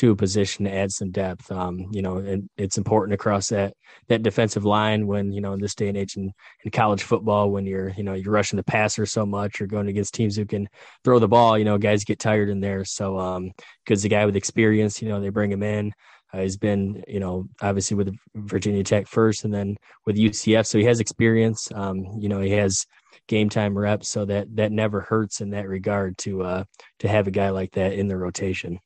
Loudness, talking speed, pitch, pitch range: -23 LUFS, 235 wpm, 100 Hz, 100-105 Hz